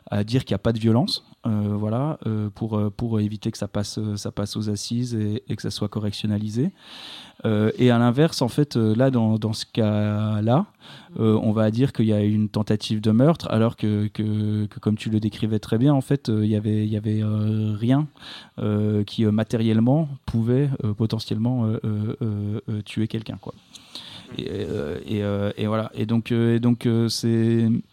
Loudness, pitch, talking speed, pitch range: -23 LUFS, 110 Hz, 200 wpm, 105-115 Hz